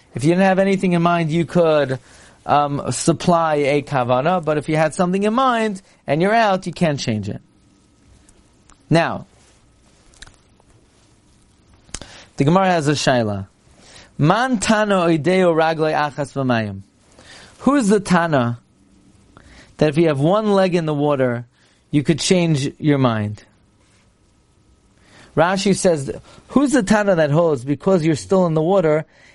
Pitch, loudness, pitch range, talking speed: 155 Hz, -18 LUFS, 120-180 Hz, 130 wpm